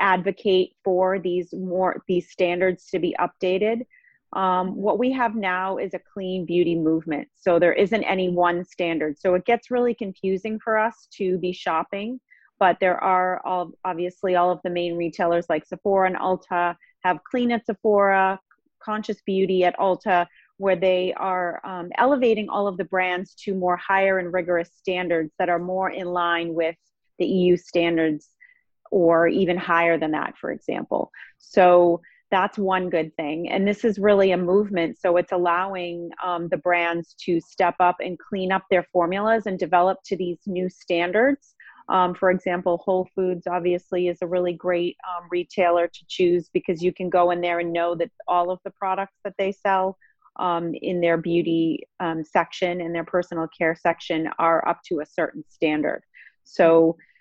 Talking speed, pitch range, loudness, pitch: 175 wpm, 175-190 Hz, -23 LUFS, 180 Hz